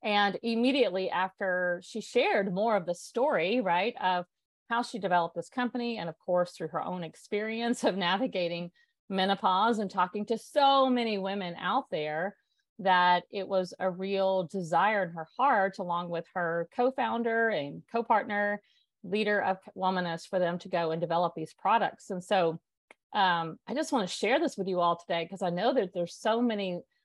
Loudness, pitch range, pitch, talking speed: -30 LUFS, 175-225 Hz, 190 Hz, 180 wpm